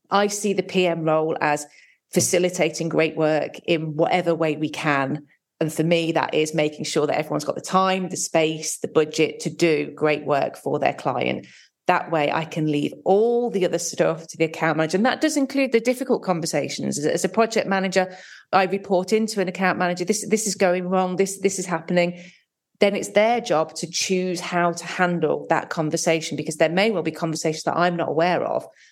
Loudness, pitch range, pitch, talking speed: -22 LUFS, 160-190 Hz, 175 Hz, 205 wpm